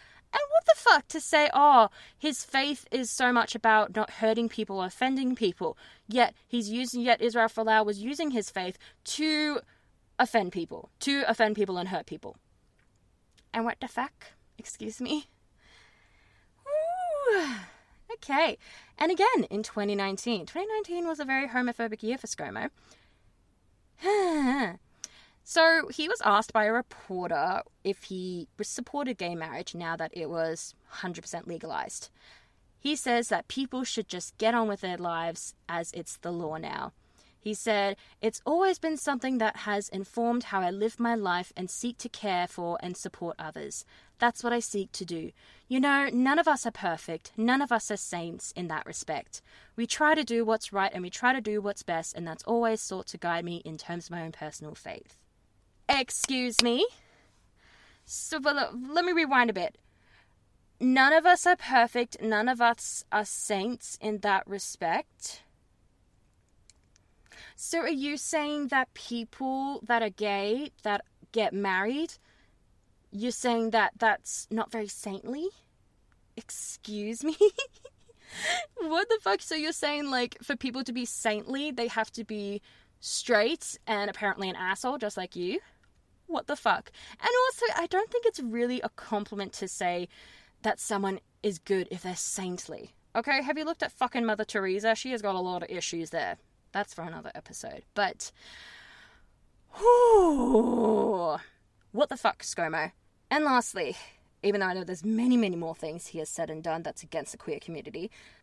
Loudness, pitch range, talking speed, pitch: -29 LUFS, 190-275 Hz, 165 wpm, 230 Hz